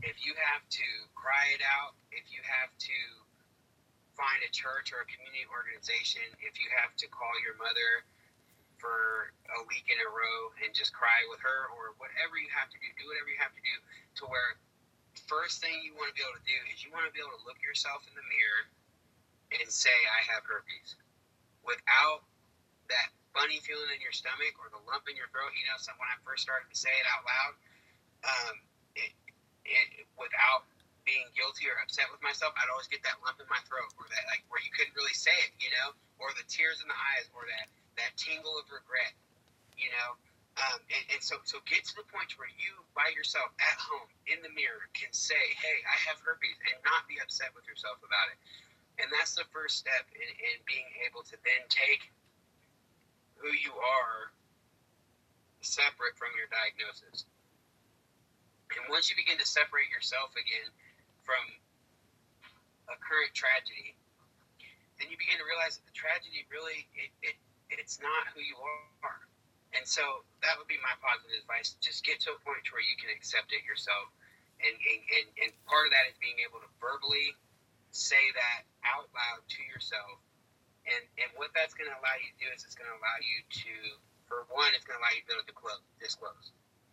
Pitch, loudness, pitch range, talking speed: 150 Hz, -32 LUFS, 130-205 Hz, 200 wpm